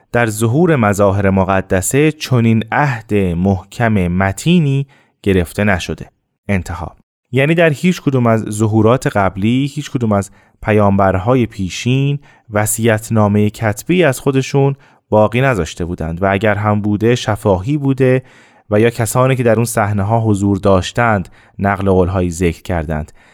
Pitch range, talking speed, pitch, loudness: 95-130 Hz, 135 wpm, 110 Hz, -15 LUFS